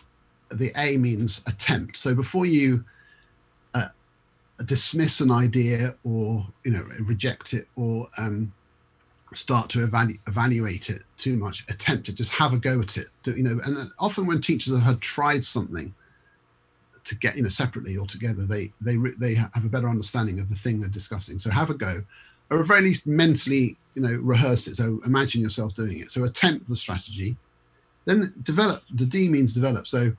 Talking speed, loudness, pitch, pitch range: 185 wpm, -25 LUFS, 120 Hz, 105-130 Hz